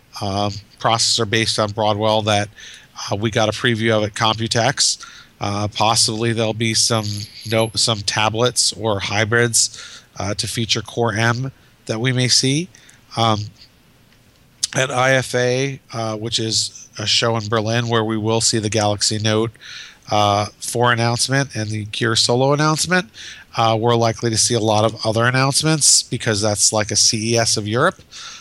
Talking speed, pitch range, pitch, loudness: 160 wpm, 110-120 Hz, 115 Hz, -17 LUFS